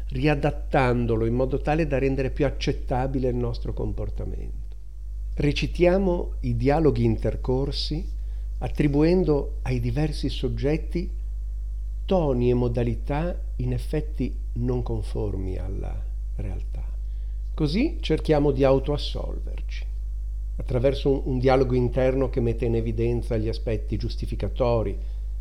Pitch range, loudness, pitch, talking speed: 105-140 Hz, -26 LUFS, 125 Hz, 100 wpm